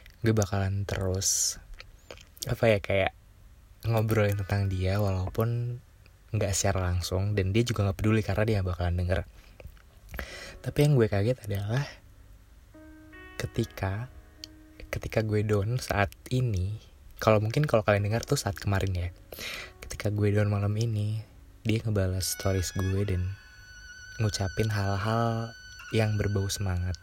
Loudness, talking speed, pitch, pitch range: -29 LUFS, 125 wpm, 100 Hz, 95-110 Hz